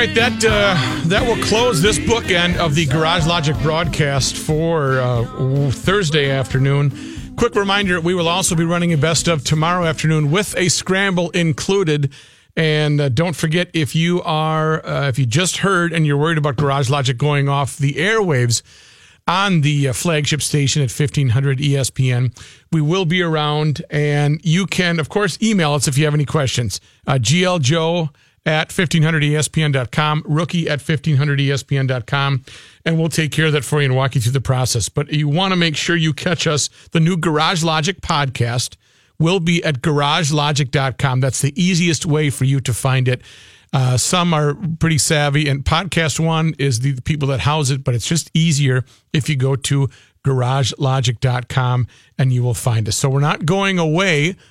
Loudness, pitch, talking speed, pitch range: -17 LUFS, 150 Hz, 175 wpm, 135-165 Hz